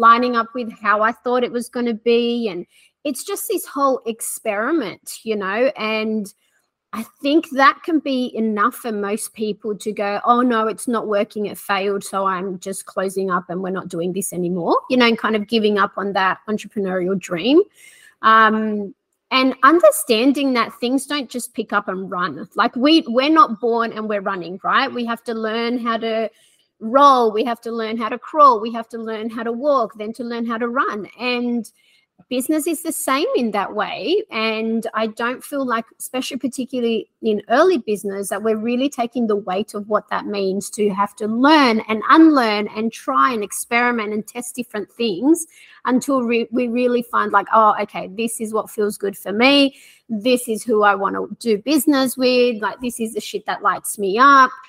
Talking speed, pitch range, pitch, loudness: 200 wpm, 210-255 Hz, 230 Hz, -19 LUFS